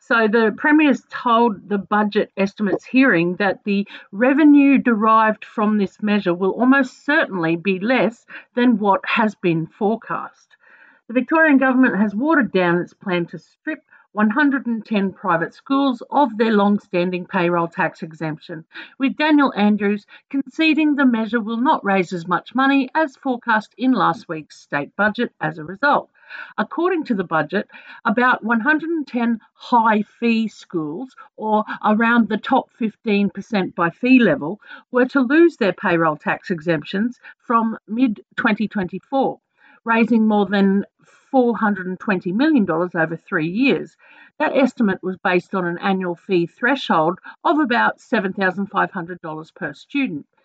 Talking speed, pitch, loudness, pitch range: 140 wpm, 215 Hz, -19 LUFS, 185-260 Hz